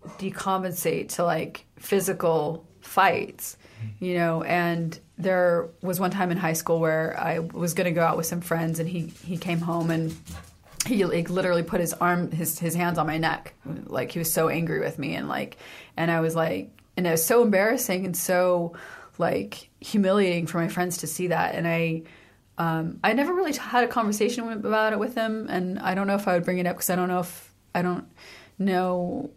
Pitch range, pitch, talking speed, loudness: 165-185 Hz, 175 Hz, 205 wpm, -25 LUFS